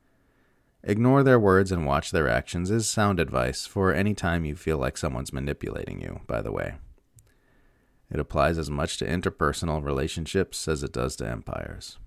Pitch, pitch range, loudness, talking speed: 85 Hz, 70-95 Hz, -26 LUFS, 170 wpm